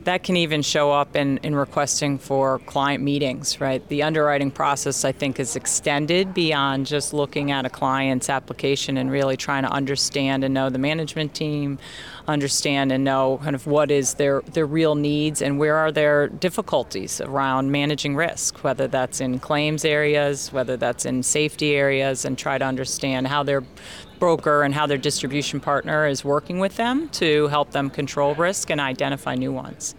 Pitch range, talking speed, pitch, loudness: 135-150 Hz, 180 wpm, 145 Hz, -22 LUFS